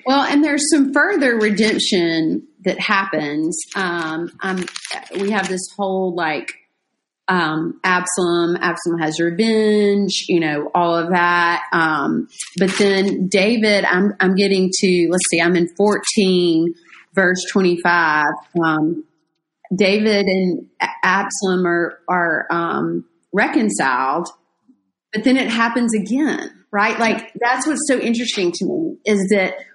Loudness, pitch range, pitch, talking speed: -17 LUFS, 170-215 Hz, 190 Hz, 130 wpm